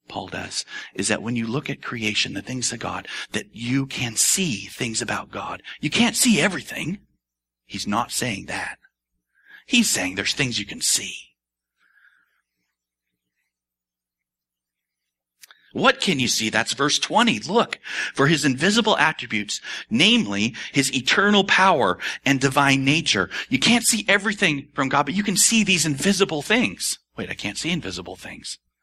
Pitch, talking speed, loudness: 125 Hz, 150 wpm, -21 LUFS